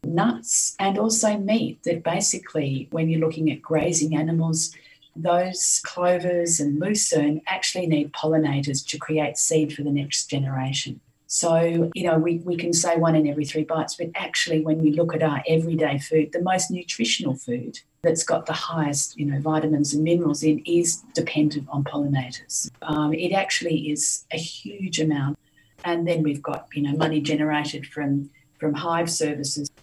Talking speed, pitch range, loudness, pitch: 170 wpm, 150-170 Hz, -23 LUFS, 155 Hz